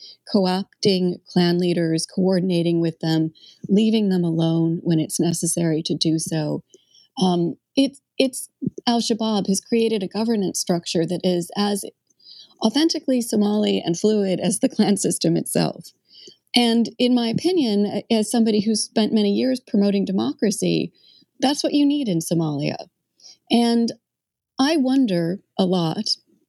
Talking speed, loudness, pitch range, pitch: 135 wpm, -21 LUFS, 175-235 Hz, 205 Hz